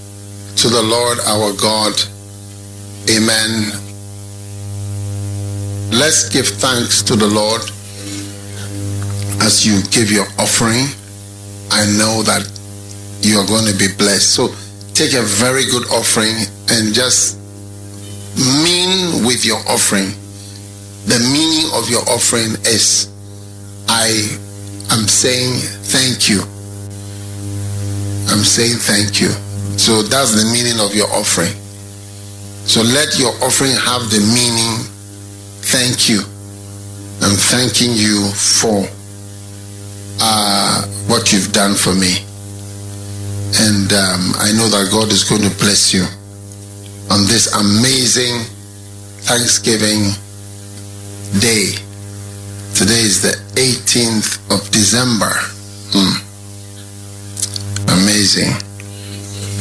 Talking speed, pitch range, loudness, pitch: 105 wpm, 100-110 Hz, -12 LUFS, 100 Hz